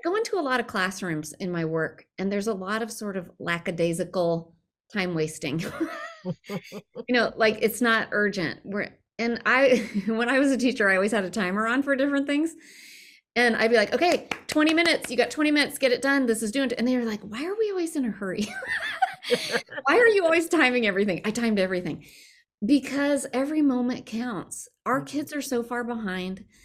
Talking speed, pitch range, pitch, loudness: 200 wpm, 195-280 Hz, 235 Hz, -25 LUFS